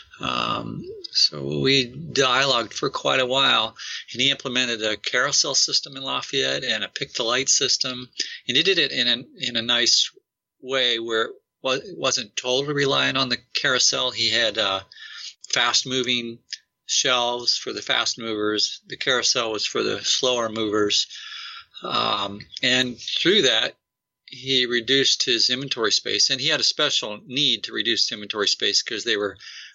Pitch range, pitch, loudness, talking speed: 115-135 Hz, 125 Hz, -21 LUFS, 160 wpm